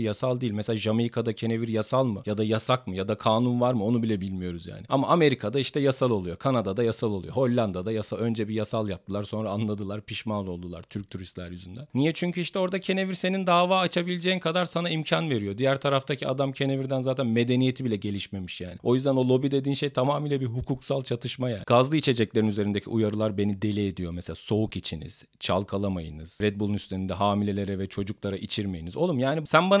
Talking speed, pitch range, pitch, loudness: 190 wpm, 100-135 Hz, 115 Hz, -27 LUFS